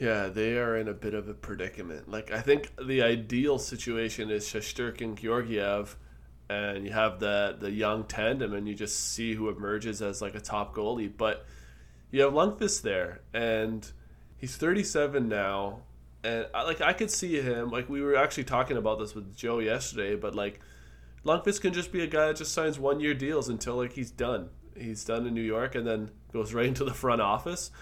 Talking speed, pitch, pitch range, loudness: 205 wpm, 110 Hz, 105-130 Hz, -30 LUFS